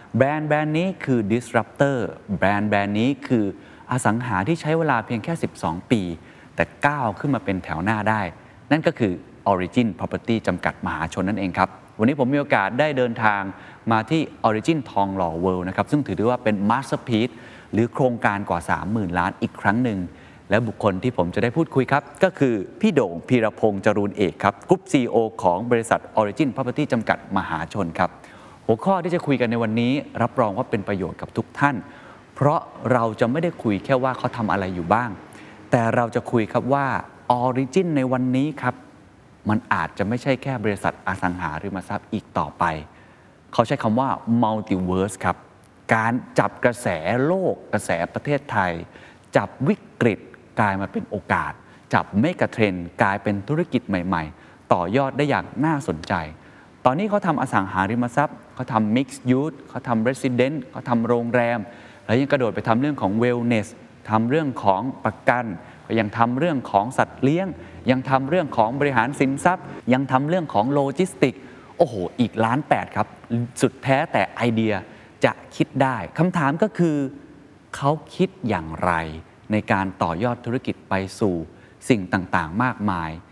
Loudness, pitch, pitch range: -22 LUFS, 120 Hz, 100-135 Hz